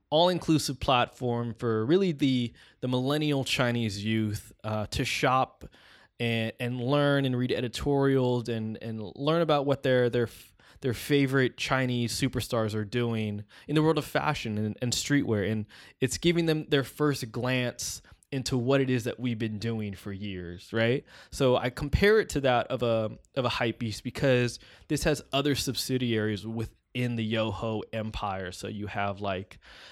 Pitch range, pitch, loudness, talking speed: 110-140 Hz, 125 Hz, -28 LUFS, 160 wpm